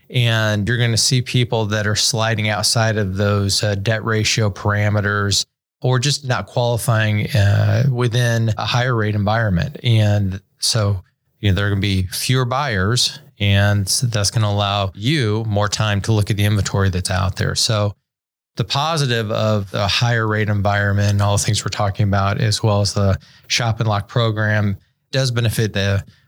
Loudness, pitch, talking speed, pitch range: -18 LUFS, 105 Hz, 185 wpm, 100-120 Hz